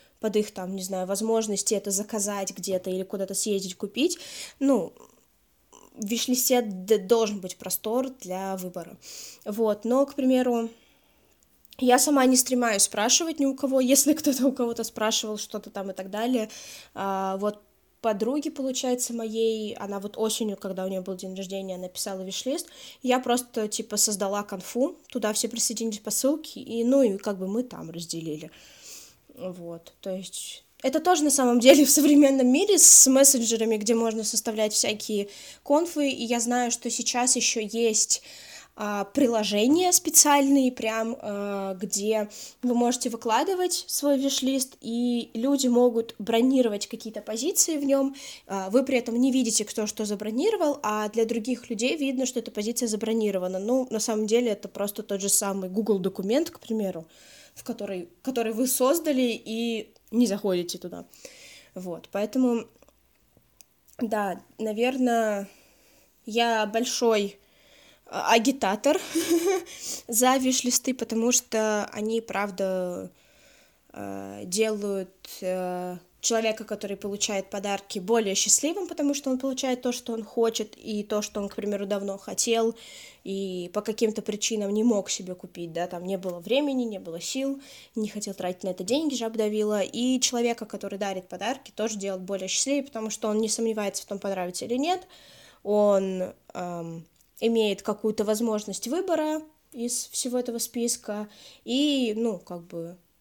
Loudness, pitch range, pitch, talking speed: -25 LUFS, 200-255 Hz, 225 Hz, 145 wpm